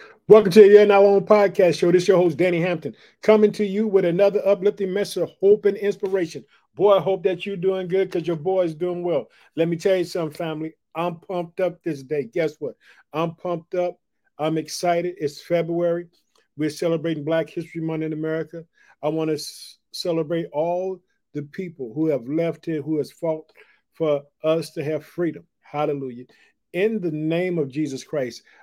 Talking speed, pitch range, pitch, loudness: 190 wpm, 155-190 Hz, 170 Hz, -21 LUFS